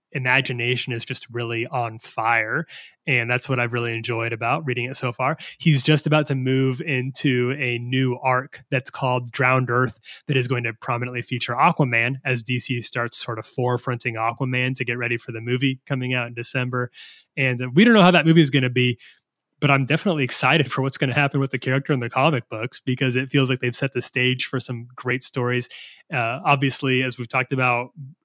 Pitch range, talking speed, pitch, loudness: 125-135 Hz, 210 wpm, 130 Hz, -22 LUFS